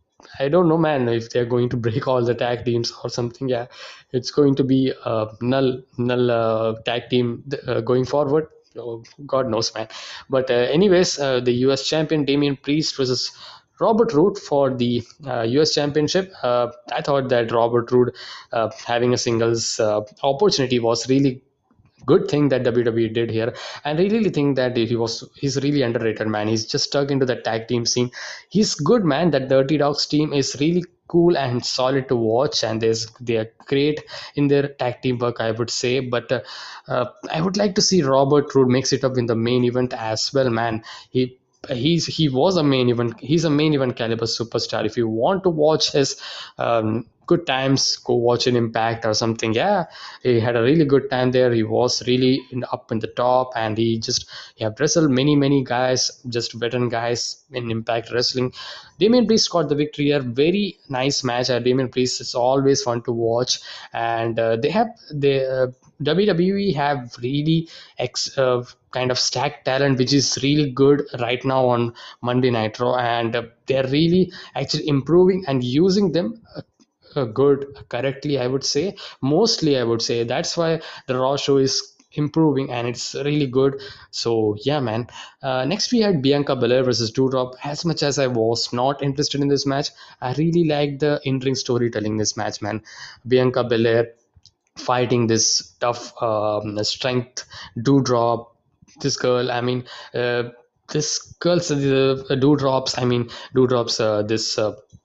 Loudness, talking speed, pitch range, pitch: -20 LUFS, 180 wpm, 120-145 Hz, 130 Hz